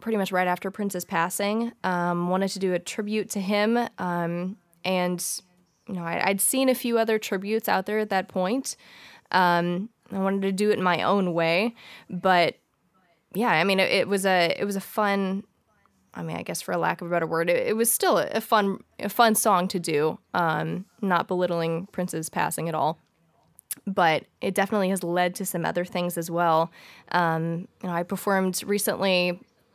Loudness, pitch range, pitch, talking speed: -25 LUFS, 175-205 Hz, 190 Hz, 200 wpm